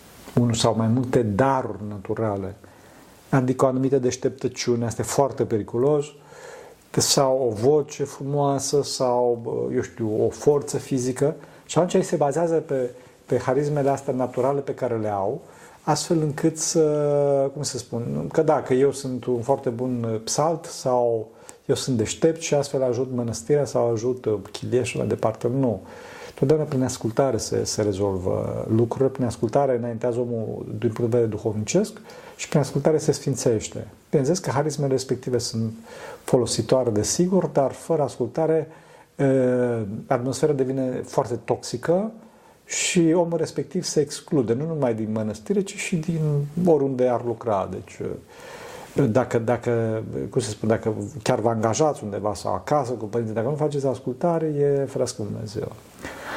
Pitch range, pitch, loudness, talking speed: 115-150 Hz, 130 Hz, -23 LUFS, 150 wpm